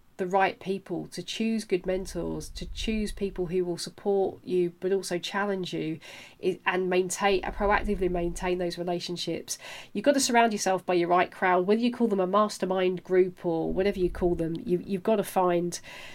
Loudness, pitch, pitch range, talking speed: -28 LUFS, 185 Hz, 175-200 Hz, 185 wpm